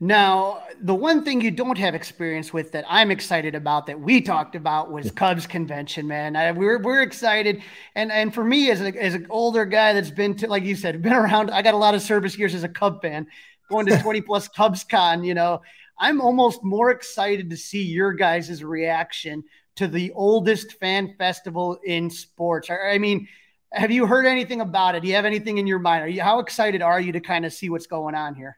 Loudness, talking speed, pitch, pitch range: -21 LUFS, 225 wpm, 195 Hz, 170-215 Hz